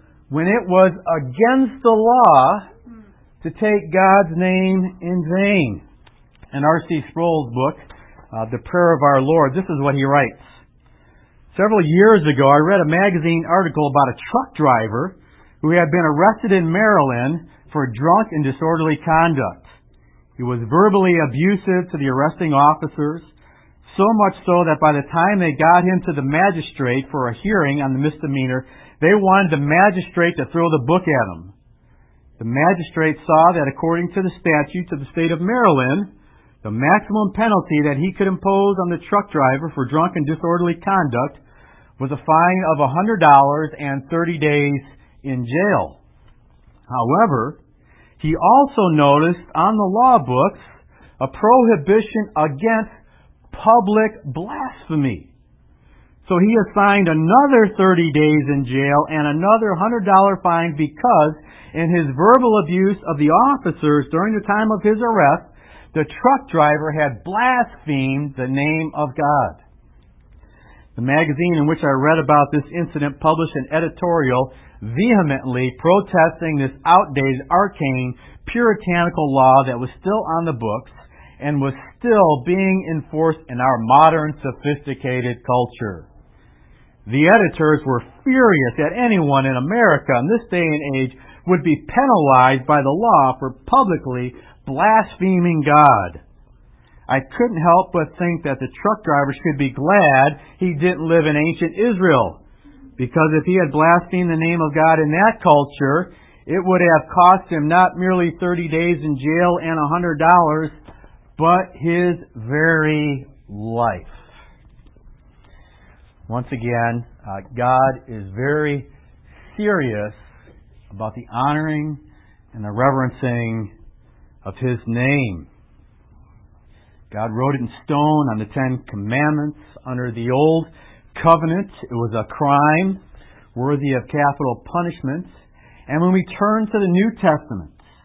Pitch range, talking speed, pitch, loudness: 135-180 Hz, 140 wpm, 155 Hz, -17 LUFS